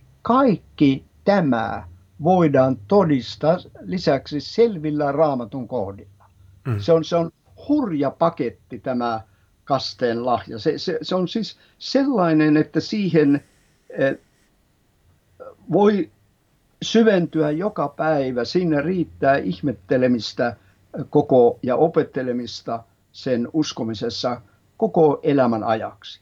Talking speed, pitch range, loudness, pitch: 90 wpm, 115-165 Hz, -21 LUFS, 140 Hz